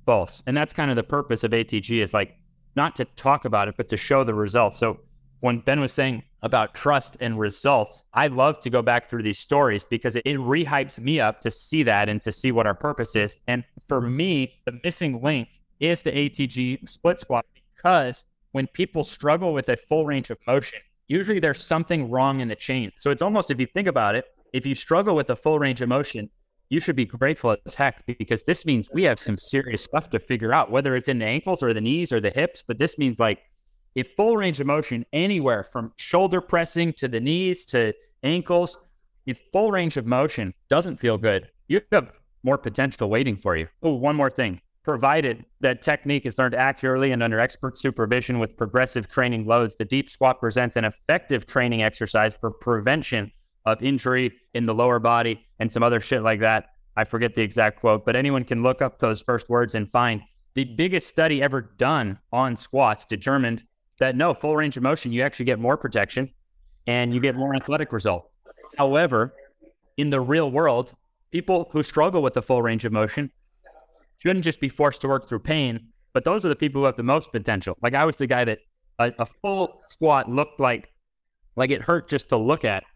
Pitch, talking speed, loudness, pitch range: 130 Hz, 210 wpm, -23 LUFS, 115-145 Hz